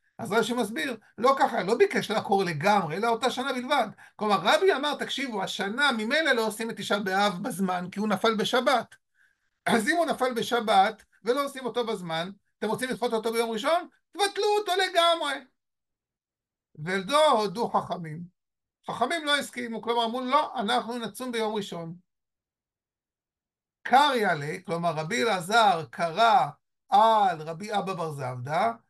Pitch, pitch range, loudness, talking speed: 230 Hz, 200-265 Hz, -26 LUFS, 145 wpm